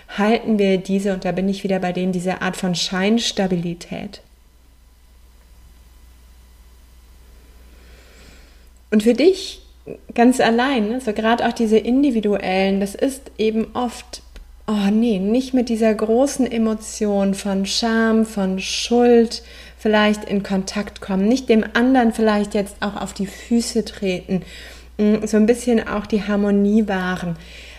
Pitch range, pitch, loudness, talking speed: 185-230 Hz, 205 Hz, -19 LUFS, 130 wpm